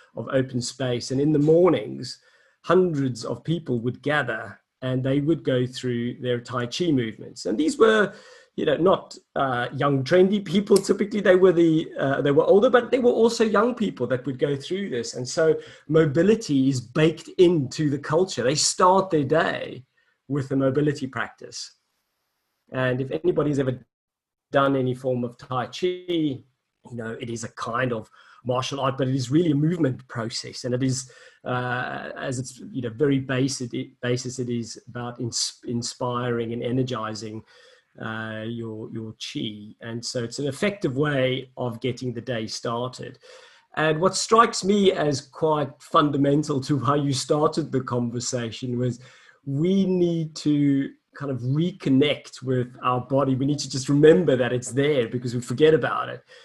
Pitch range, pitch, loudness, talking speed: 125-160 Hz, 135 Hz, -23 LUFS, 170 wpm